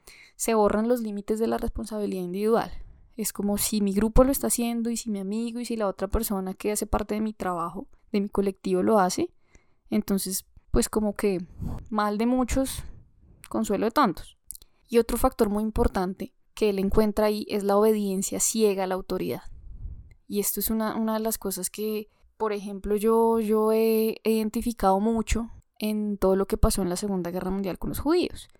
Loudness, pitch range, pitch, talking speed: -26 LUFS, 195-225 Hz, 210 Hz, 190 wpm